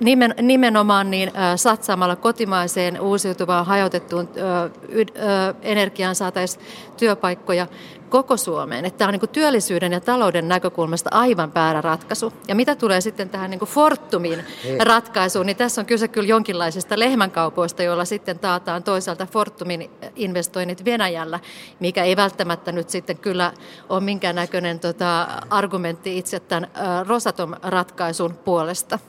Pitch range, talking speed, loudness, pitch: 175-215 Hz, 120 wpm, -20 LUFS, 185 Hz